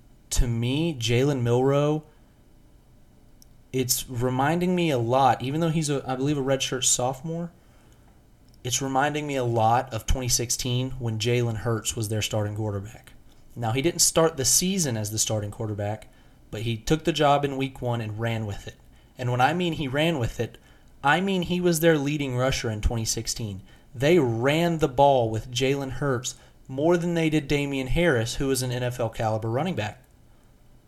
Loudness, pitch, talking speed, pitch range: -25 LUFS, 130 Hz, 175 wpm, 115-145 Hz